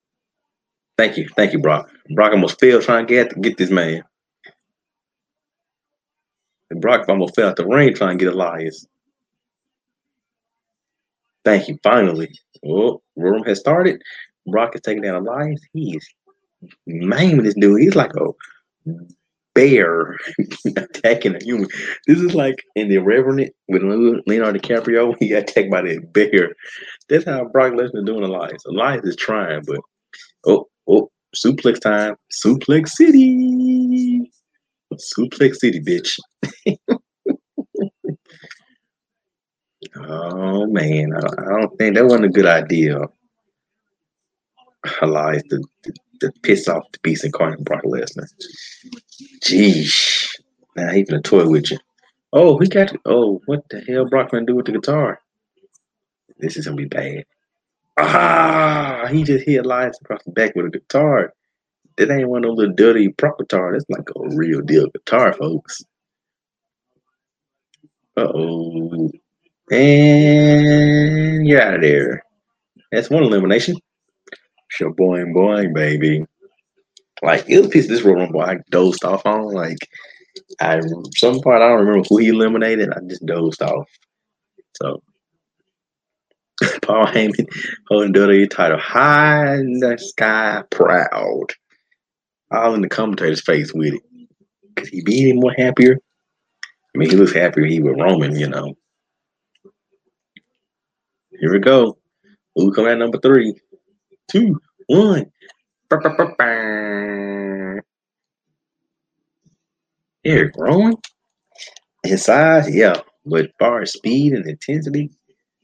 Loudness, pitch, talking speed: -16 LUFS, 130 Hz, 130 wpm